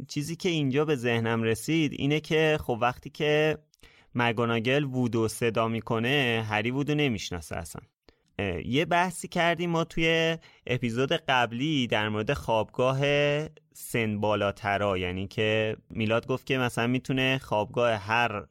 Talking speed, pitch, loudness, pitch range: 125 wpm, 125 Hz, -27 LUFS, 115-150 Hz